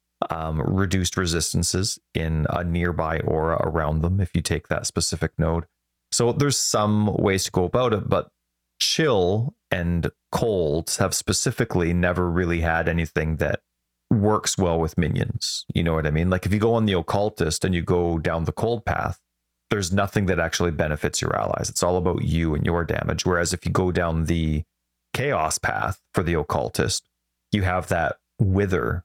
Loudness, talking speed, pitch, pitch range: -23 LUFS, 180 wpm, 85 Hz, 80-100 Hz